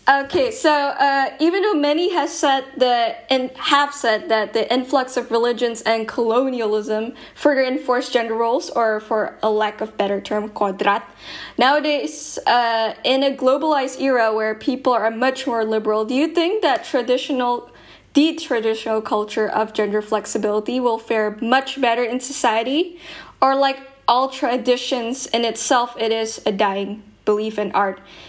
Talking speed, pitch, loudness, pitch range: 155 wpm, 245 Hz, -19 LUFS, 220-275 Hz